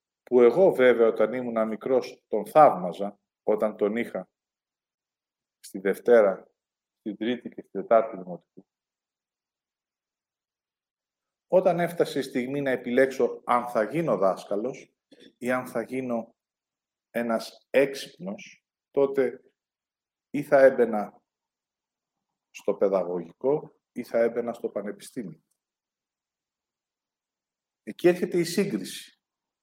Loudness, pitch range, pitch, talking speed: -25 LUFS, 110-135 Hz, 120 Hz, 100 wpm